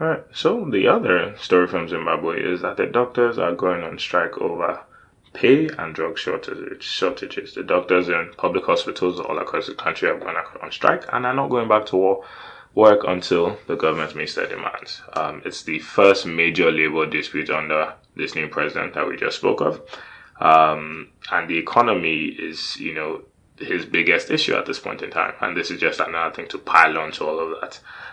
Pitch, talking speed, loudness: 125 Hz, 190 wpm, -21 LUFS